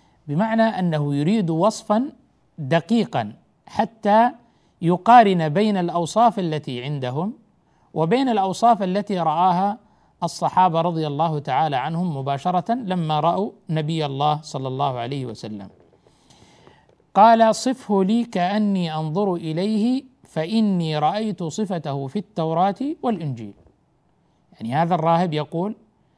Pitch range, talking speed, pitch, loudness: 155-215 Hz, 105 wpm, 180 Hz, -21 LUFS